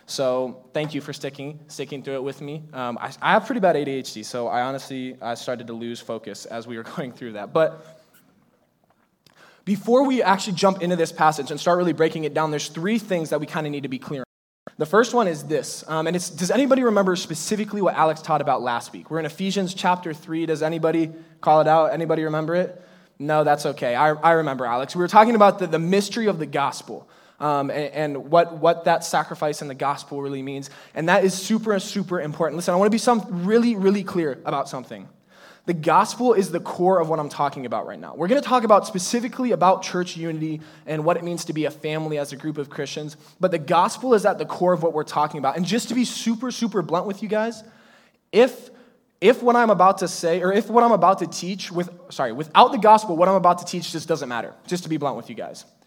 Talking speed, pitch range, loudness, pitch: 240 wpm, 150-195 Hz, -22 LUFS, 165 Hz